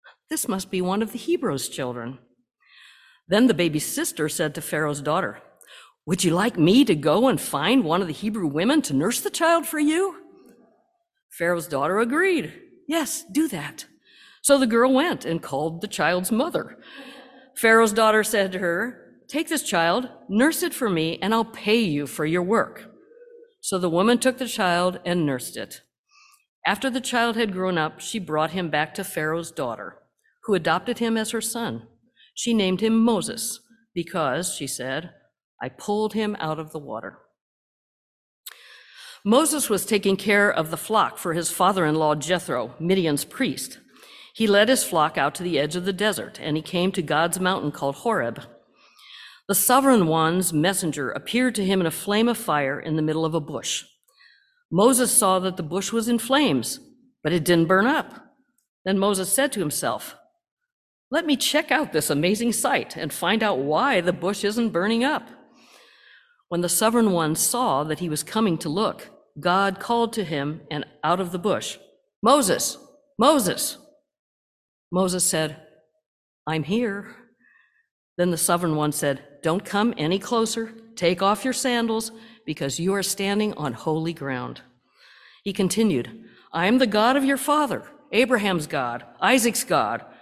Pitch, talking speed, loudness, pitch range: 200 Hz, 170 wpm, -23 LUFS, 165-250 Hz